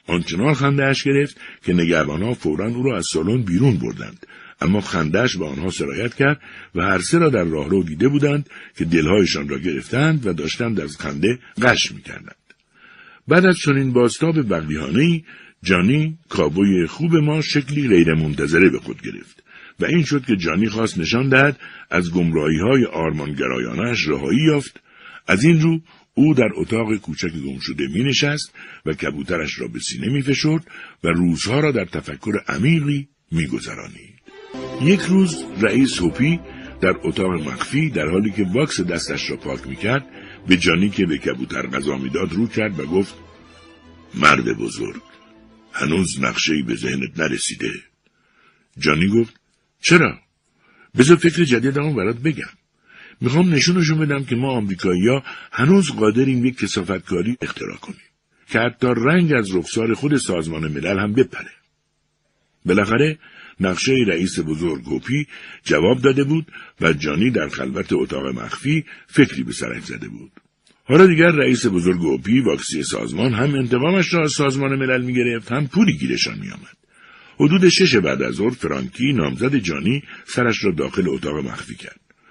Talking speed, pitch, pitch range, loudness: 155 wpm, 125 Hz, 85-145 Hz, -19 LUFS